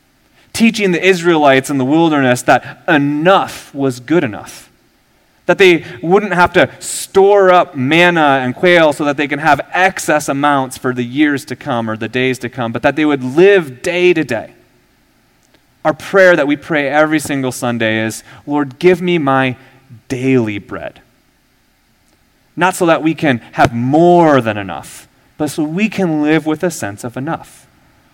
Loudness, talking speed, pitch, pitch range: -13 LUFS, 170 wpm, 150 Hz, 130-175 Hz